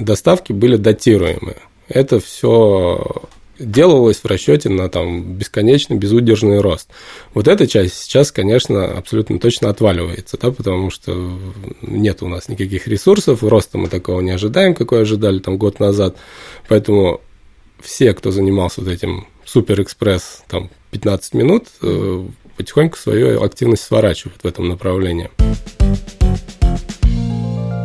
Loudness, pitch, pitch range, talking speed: -15 LUFS, 100 Hz, 90-110 Hz, 120 wpm